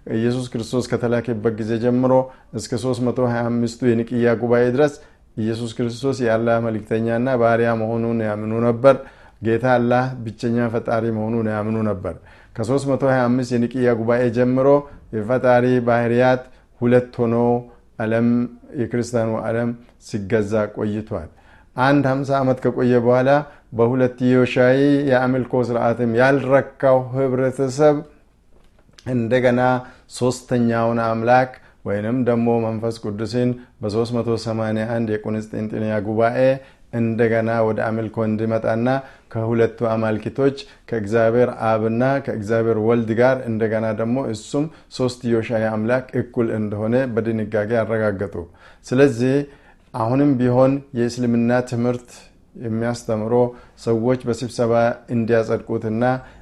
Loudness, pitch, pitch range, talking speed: -20 LUFS, 120 Hz, 115-125 Hz, 95 wpm